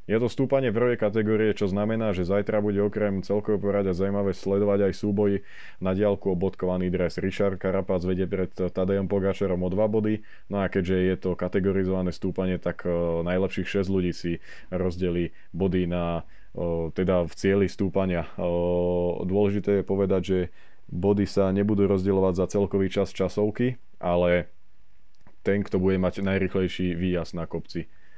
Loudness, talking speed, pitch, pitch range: -26 LUFS, 150 wpm, 95 Hz, 90-100 Hz